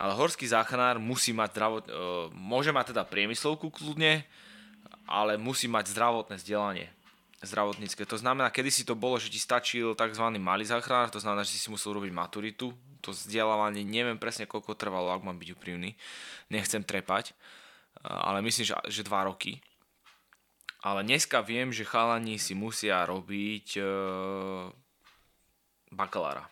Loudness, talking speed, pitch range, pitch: -30 LUFS, 140 wpm, 100-120 Hz, 110 Hz